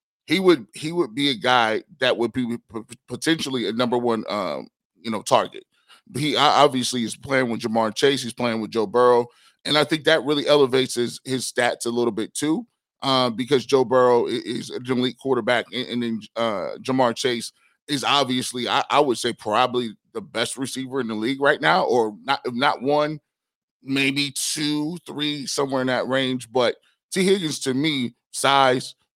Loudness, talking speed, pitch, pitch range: -22 LUFS, 190 wpm, 130 Hz, 120-145 Hz